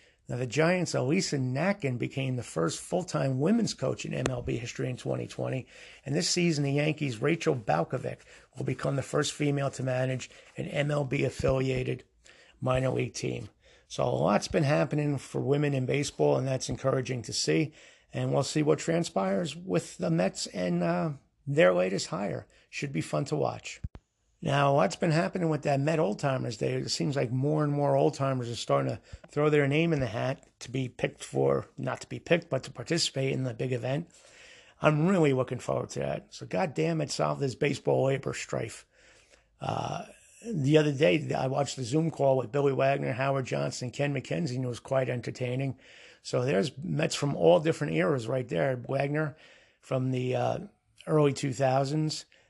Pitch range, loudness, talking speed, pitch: 130-155 Hz, -29 LUFS, 185 wpm, 140 Hz